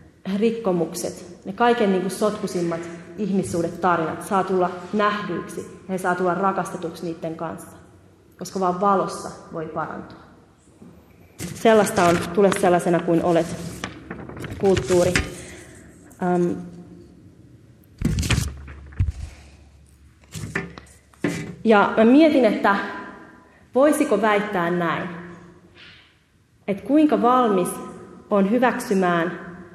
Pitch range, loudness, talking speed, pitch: 170-200 Hz, -21 LUFS, 85 wpm, 180 Hz